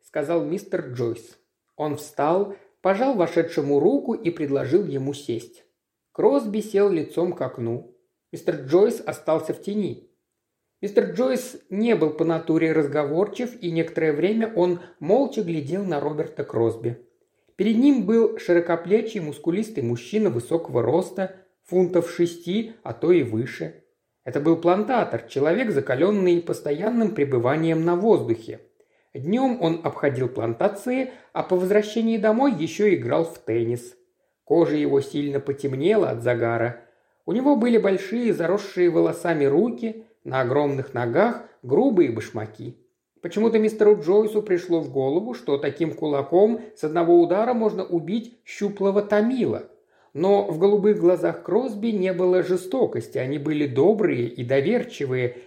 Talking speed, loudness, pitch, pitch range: 130 wpm, -23 LUFS, 175 Hz, 150-215 Hz